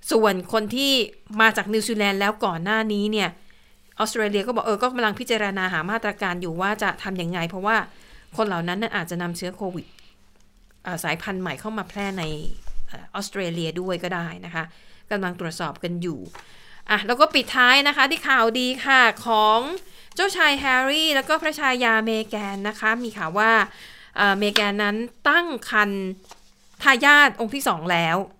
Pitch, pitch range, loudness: 210 Hz, 185-235 Hz, -21 LUFS